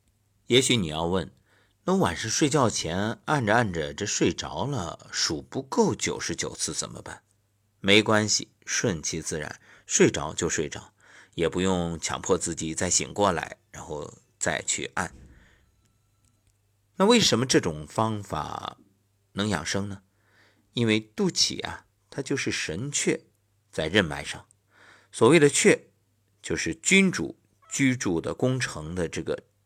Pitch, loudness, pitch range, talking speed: 100 Hz, -25 LUFS, 95-110 Hz, 200 characters per minute